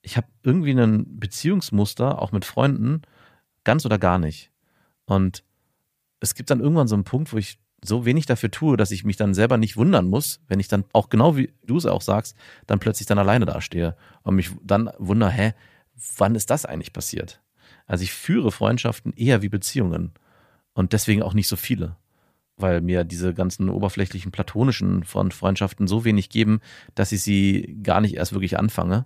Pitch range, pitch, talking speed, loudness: 95-115 Hz, 105 Hz, 190 wpm, -22 LUFS